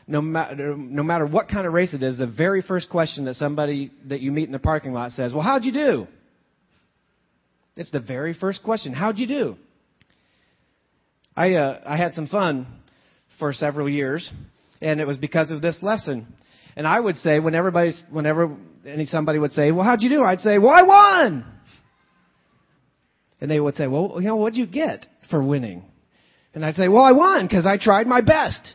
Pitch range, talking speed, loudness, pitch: 145-195 Hz, 195 wpm, -20 LUFS, 160 Hz